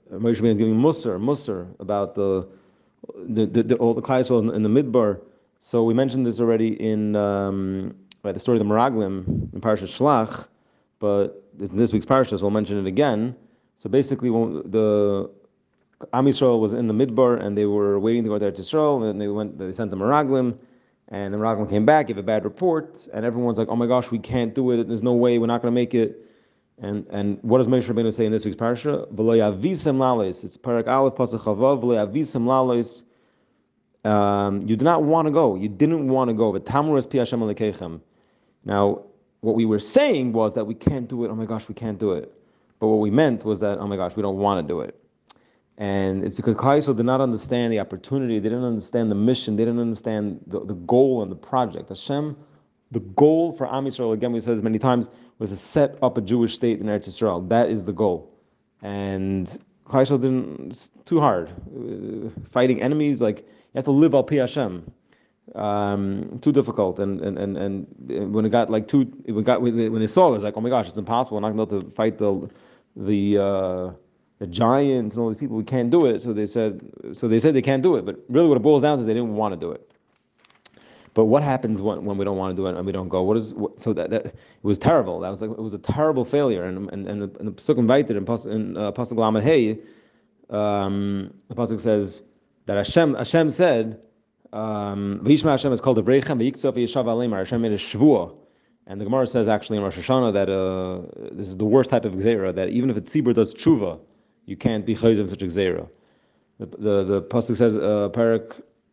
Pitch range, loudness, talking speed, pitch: 105-125 Hz, -22 LUFS, 210 wpm, 110 Hz